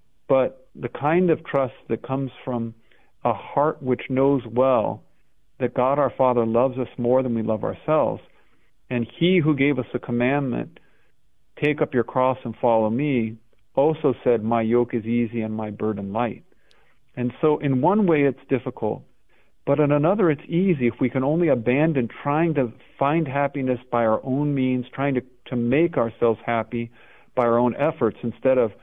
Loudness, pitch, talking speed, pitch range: -23 LUFS, 130 Hz, 175 wpm, 120-140 Hz